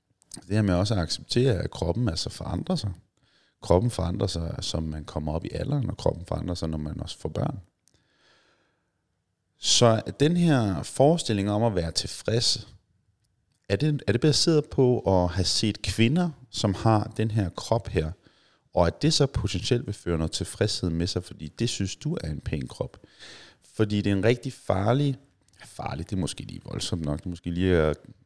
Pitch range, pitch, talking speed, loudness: 90-125 Hz, 105 Hz, 190 wpm, -26 LUFS